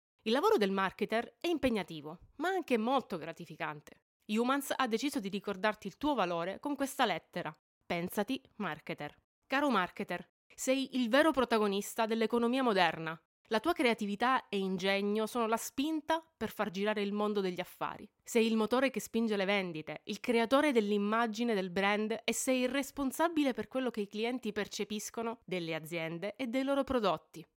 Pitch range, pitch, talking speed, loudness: 200-260 Hz, 225 Hz, 160 wpm, -33 LUFS